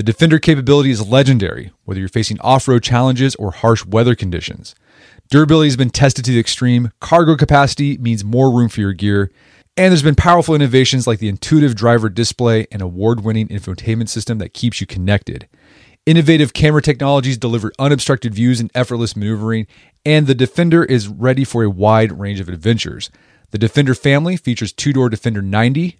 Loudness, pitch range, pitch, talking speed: -14 LUFS, 110-140 Hz, 120 Hz, 180 wpm